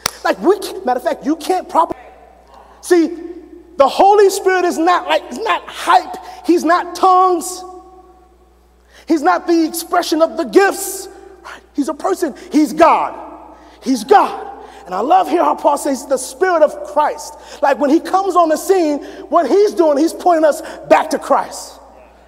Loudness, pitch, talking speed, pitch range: -15 LUFS, 345 Hz, 165 wpm, 310-370 Hz